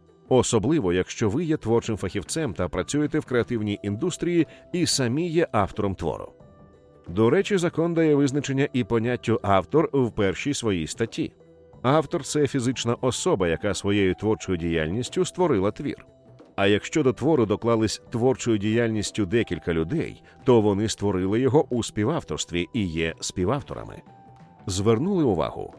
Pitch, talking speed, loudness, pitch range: 115 Hz, 135 wpm, -24 LUFS, 100-140 Hz